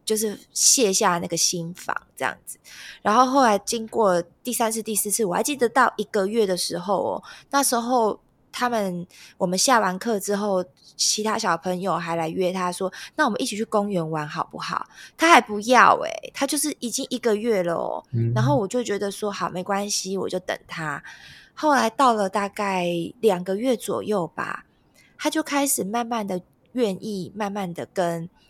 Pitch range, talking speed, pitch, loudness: 180-235 Hz, 260 characters per minute, 205 Hz, -23 LUFS